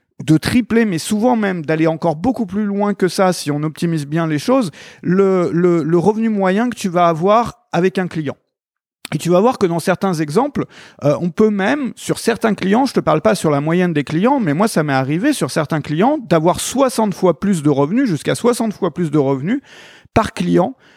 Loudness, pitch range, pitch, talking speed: -16 LUFS, 160-220 Hz, 185 Hz, 220 wpm